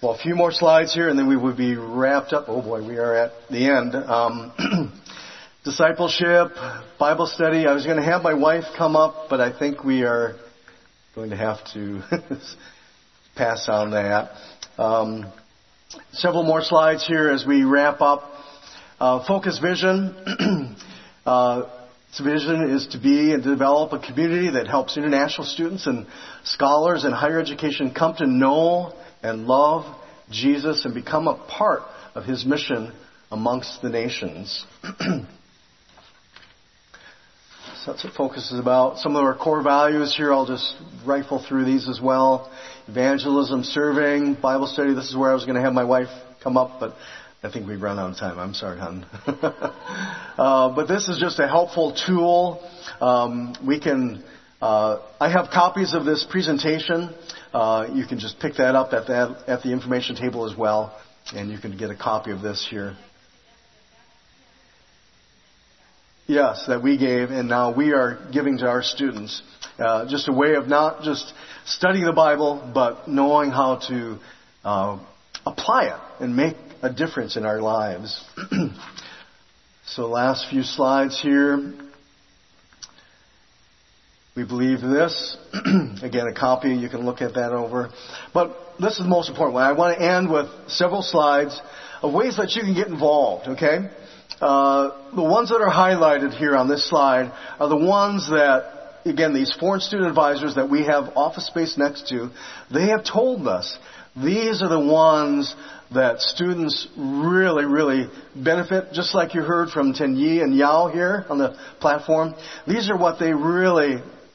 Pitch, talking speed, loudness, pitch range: 140 Hz, 165 wpm, -21 LUFS, 125-160 Hz